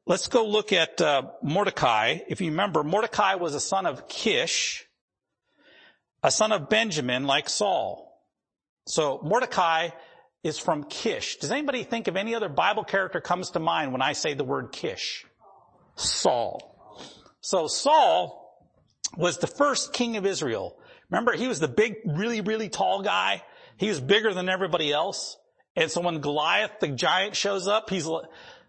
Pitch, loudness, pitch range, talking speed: 195 Hz, -25 LUFS, 170-220 Hz, 160 wpm